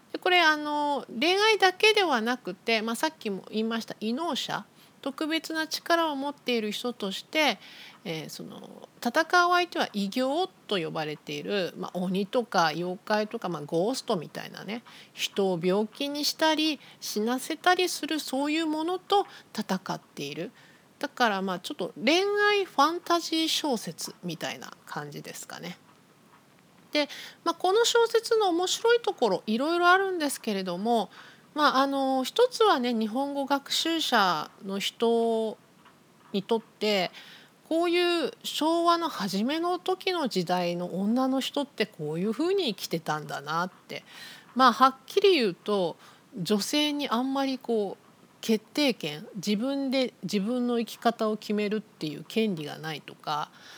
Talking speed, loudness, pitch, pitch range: 295 characters per minute, -27 LUFS, 245 Hz, 200-315 Hz